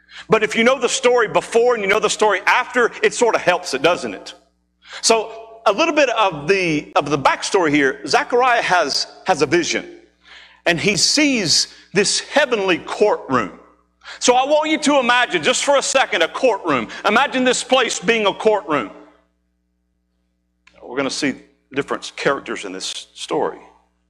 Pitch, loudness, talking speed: 215 Hz, -17 LUFS, 170 wpm